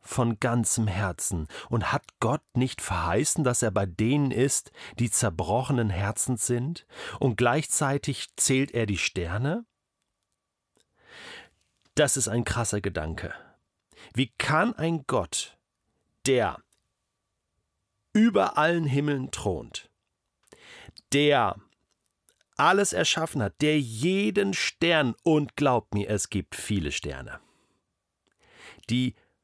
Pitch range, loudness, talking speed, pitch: 105-145 Hz, -26 LUFS, 105 wpm, 120 Hz